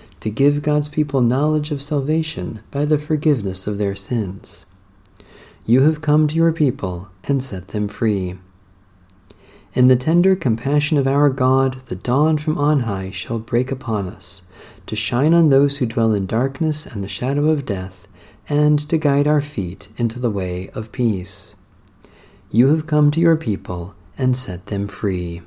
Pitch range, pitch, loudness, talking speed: 100-145 Hz, 115 Hz, -19 LUFS, 170 wpm